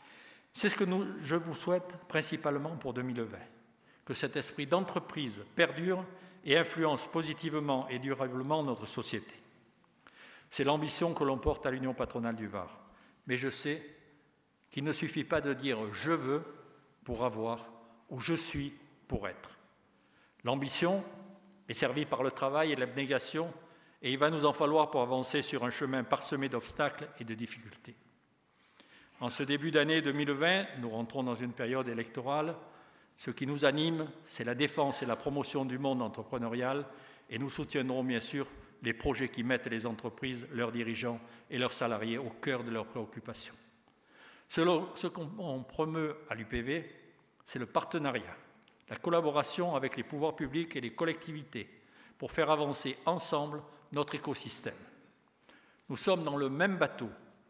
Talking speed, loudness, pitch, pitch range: 155 wpm, -34 LUFS, 140 Hz, 125-155 Hz